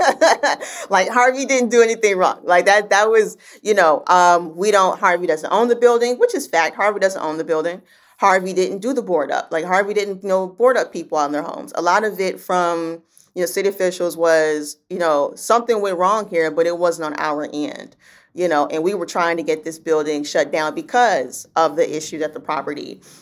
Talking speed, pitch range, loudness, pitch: 220 wpm, 165-210 Hz, -18 LUFS, 185 Hz